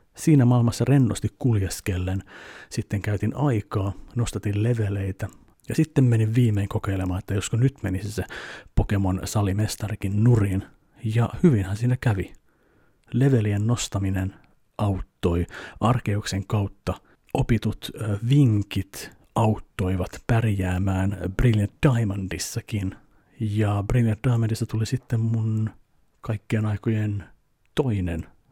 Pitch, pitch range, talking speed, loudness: 105 Hz, 100-115 Hz, 95 wpm, -24 LUFS